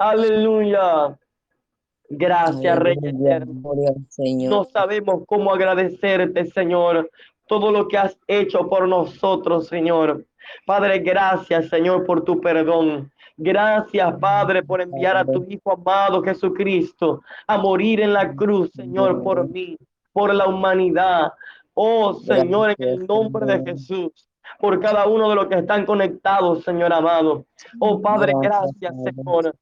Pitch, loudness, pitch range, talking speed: 185 Hz, -19 LUFS, 170-205 Hz, 130 wpm